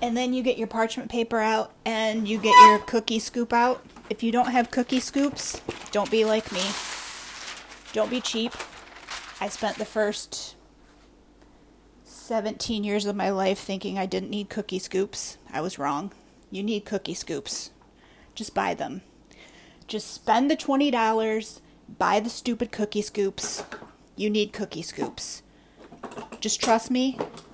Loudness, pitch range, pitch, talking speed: -25 LUFS, 205-240 Hz, 220 Hz, 150 wpm